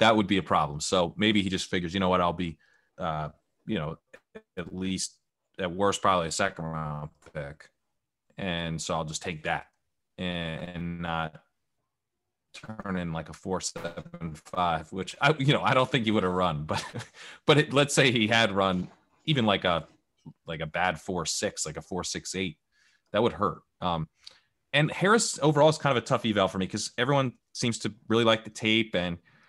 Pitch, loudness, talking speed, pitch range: 95 Hz, -27 LUFS, 200 wpm, 85-115 Hz